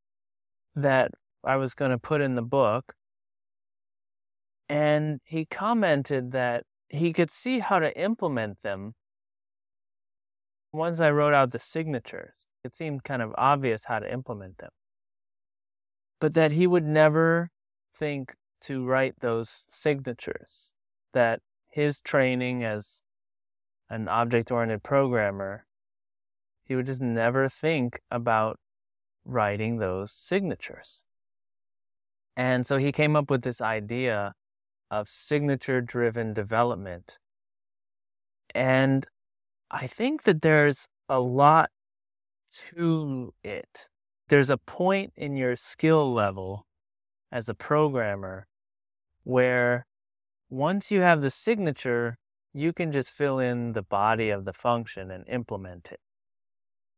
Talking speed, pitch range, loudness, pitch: 120 wpm, 100-145 Hz, -26 LUFS, 120 Hz